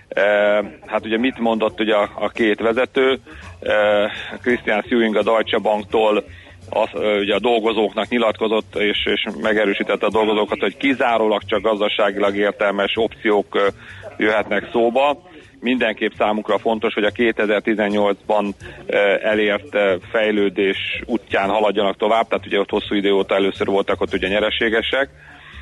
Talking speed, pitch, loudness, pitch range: 125 wpm, 105 Hz, -19 LUFS, 100-110 Hz